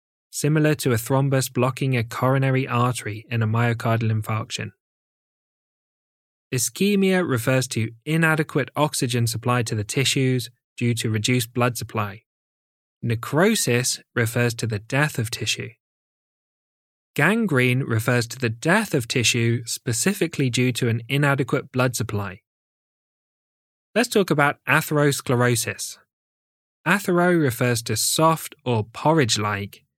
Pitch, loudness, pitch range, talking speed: 125 Hz, -22 LUFS, 115-145 Hz, 115 wpm